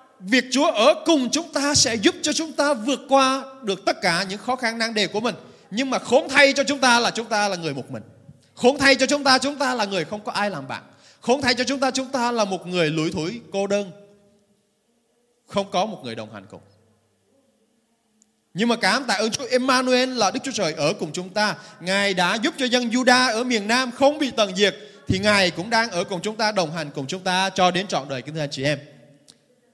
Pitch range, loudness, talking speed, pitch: 180-255 Hz, -21 LUFS, 245 wpm, 215 Hz